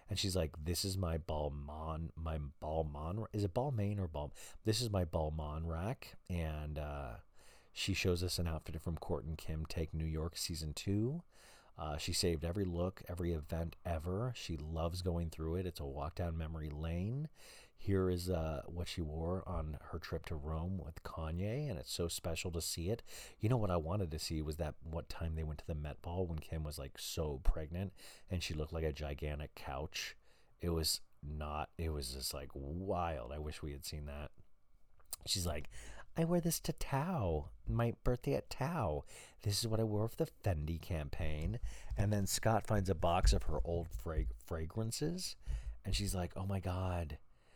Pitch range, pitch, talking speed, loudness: 80-95 Hz, 85 Hz, 195 wpm, -40 LUFS